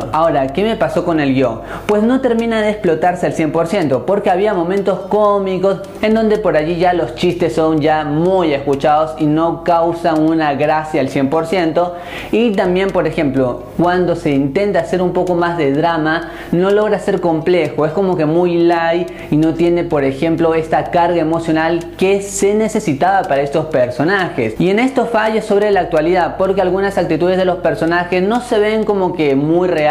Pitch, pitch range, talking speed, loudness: 170 Hz, 160-195 Hz, 185 wpm, -15 LUFS